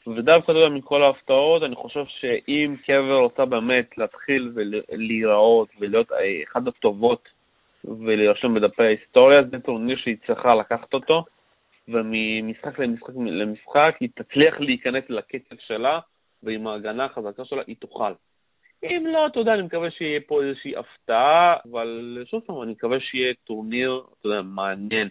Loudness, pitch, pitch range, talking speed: -21 LUFS, 130 Hz, 115-160 Hz, 130 wpm